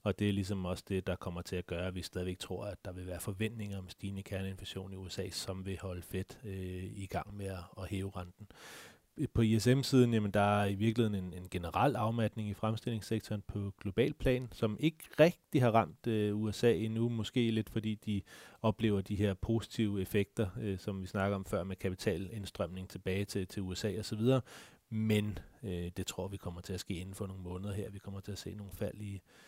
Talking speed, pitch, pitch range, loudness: 210 wpm, 100 Hz, 95-110 Hz, -36 LUFS